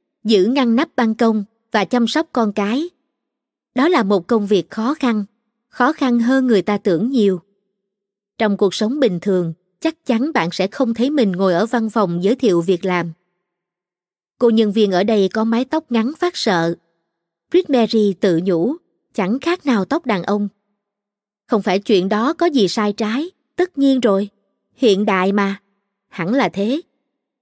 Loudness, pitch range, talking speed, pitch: -17 LUFS, 195-250 Hz, 180 wpm, 215 Hz